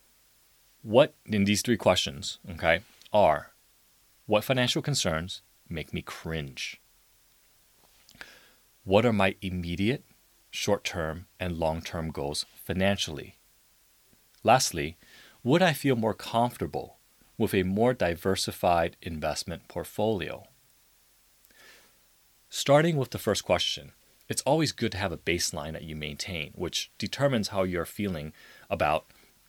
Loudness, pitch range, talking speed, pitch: -28 LUFS, 85-115 Hz, 115 wpm, 100 Hz